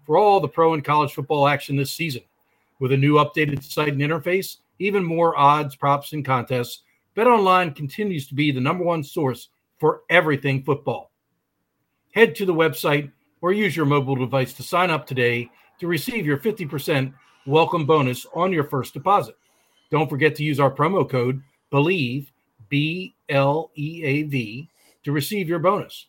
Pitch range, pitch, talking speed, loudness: 140-170 Hz, 150 Hz, 160 wpm, -21 LUFS